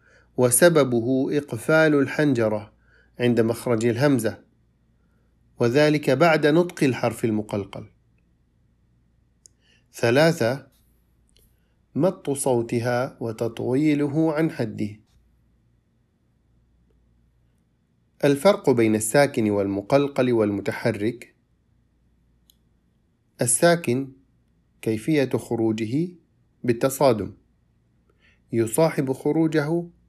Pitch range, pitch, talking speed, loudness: 110-145 Hz, 120 Hz, 55 wpm, -22 LUFS